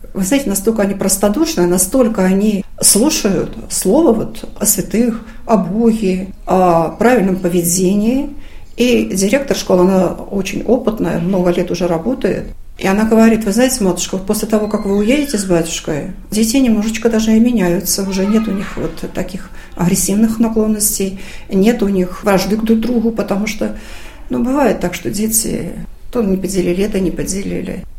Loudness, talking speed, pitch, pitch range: -14 LUFS, 155 wpm, 200 Hz, 185-225 Hz